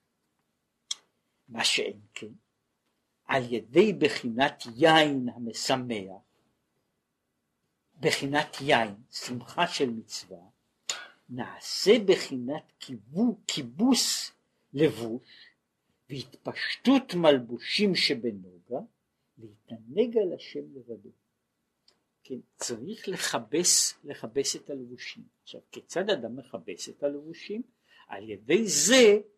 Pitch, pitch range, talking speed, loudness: 145 Hz, 120-180 Hz, 80 wpm, -27 LUFS